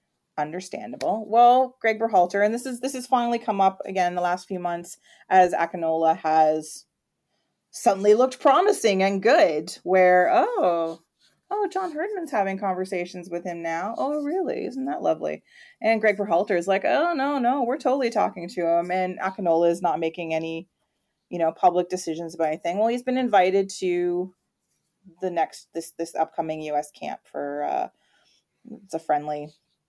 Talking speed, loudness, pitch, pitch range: 165 wpm, -23 LUFS, 185 Hz, 165-230 Hz